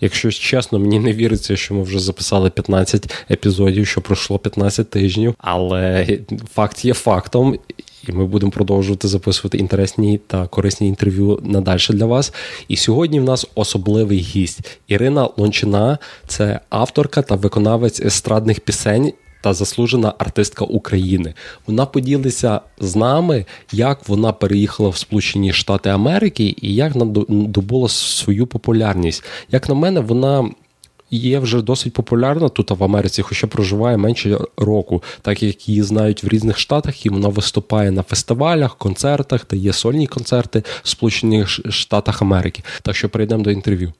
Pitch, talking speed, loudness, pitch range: 105 Hz, 145 wpm, -17 LUFS, 100-120 Hz